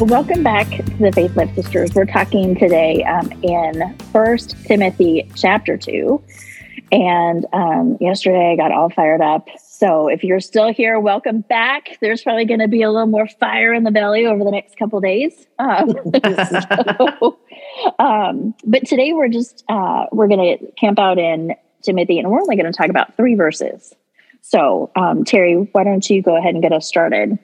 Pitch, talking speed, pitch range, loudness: 205 Hz, 185 wpm, 175-230 Hz, -15 LUFS